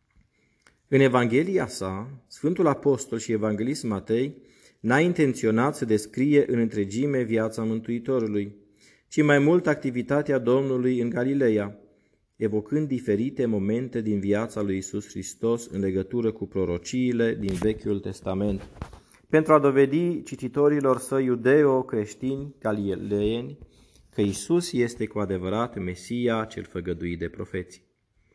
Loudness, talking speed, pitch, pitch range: -25 LUFS, 115 wpm, 115 Hz, 105-130 Hz